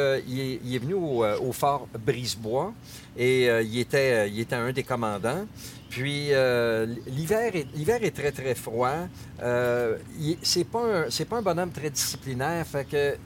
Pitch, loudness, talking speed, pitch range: 130 Hz, -27 LUFS, 185 wpm, 120-145 Hz